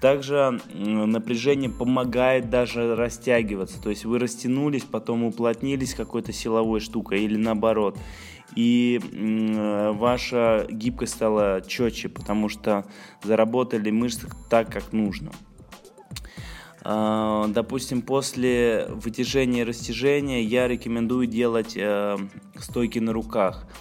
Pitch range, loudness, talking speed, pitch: 110-125 Hz, -24 LUFS, 100 wpm, 115 Hz